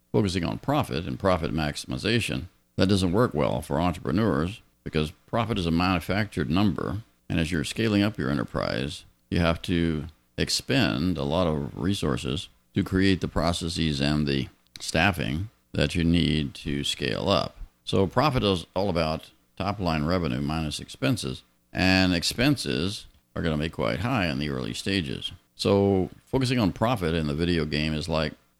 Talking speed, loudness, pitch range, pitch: 165 wpm, -26 LUFS, 75-95 Hz, 85 Hz